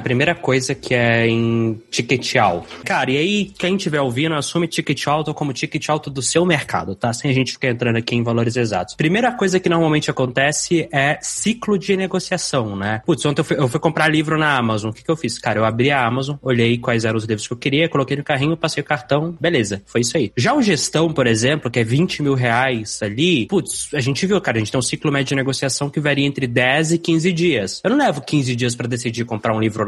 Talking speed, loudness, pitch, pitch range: 245 wpm, -18 LUFS, 140 Hz, 120-160 Hz